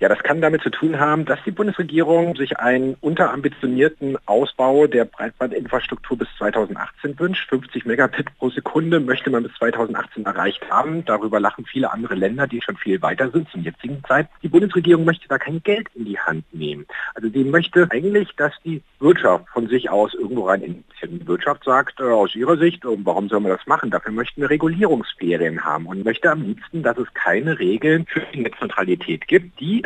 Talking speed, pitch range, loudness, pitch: 195 wpm, 130-170 Hz, -20 LUFS, 150 Hz